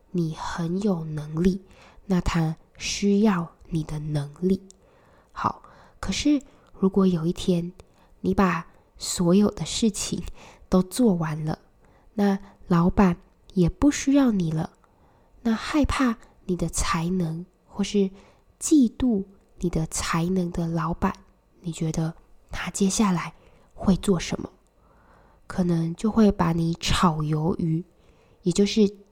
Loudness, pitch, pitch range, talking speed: -25 LUFS, 180 Hz, 165-200 Hz, 170 characters per minute